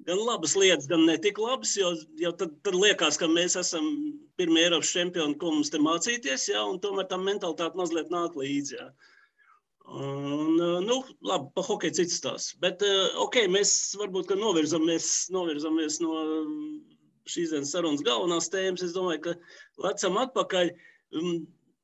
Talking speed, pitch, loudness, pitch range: 135 wpm, 175 Hz, -27 LUFS, 165-200 Hz